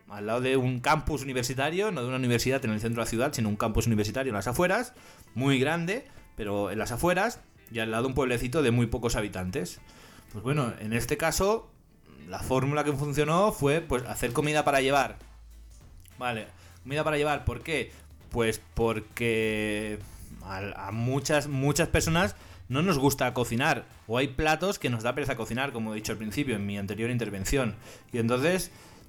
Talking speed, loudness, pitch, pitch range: 185 wpm, -28 LUFS, 120 Hz, 105-145 Hz